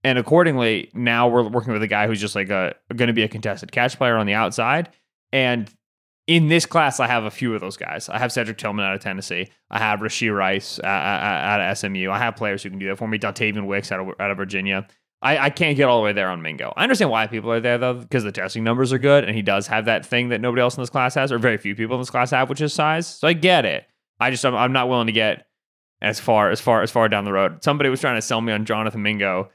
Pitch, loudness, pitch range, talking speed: 115 Hz, -20 LUFS, 105-125 Hz, 280 wpm